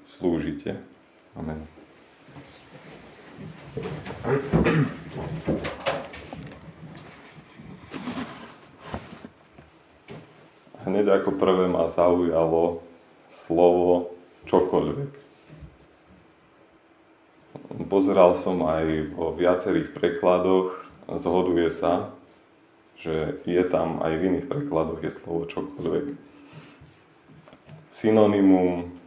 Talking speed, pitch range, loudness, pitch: 60 wpm, 85-95 Hz, -24 LUFS, 90 Hz